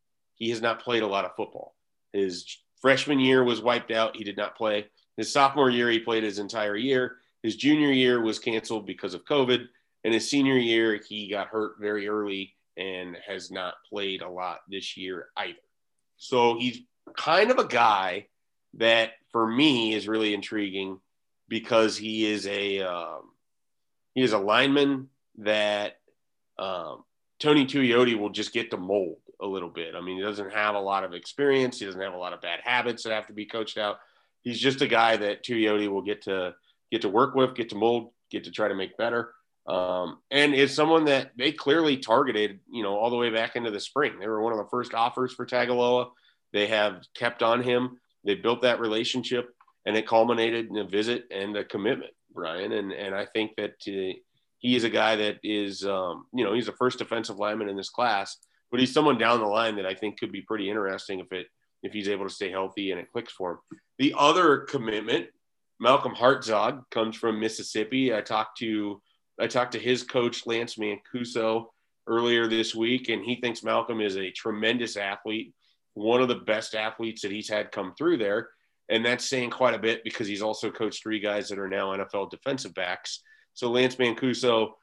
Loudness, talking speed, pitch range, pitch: -26 LUFS, 200 wpm, 105-125 Hz, 110 Hz